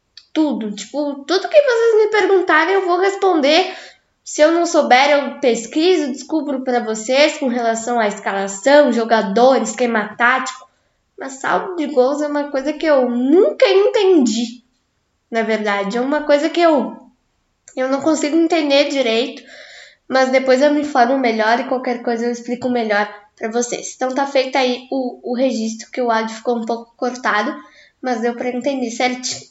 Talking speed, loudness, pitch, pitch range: 165 wpm, -16 LUFS, 260 Hz, 240-300 Hz